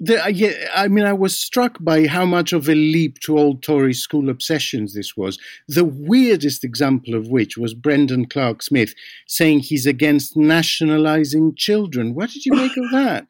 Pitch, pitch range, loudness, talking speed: 155 Hz, 140-195 Hz, -17 LUFS, 170 wpm